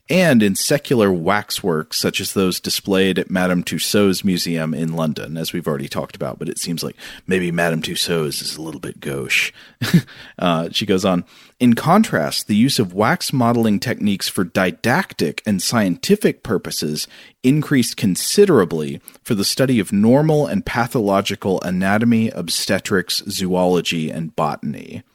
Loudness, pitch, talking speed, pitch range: -18 LUFS, 100 Hz, 150 wpm, 90-120 Hz